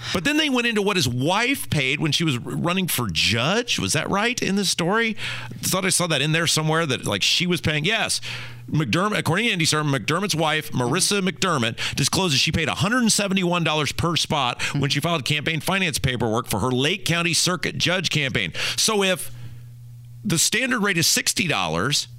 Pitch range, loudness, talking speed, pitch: 130-185 Hz, -21 LUFS, 205 wpm, 160 Hz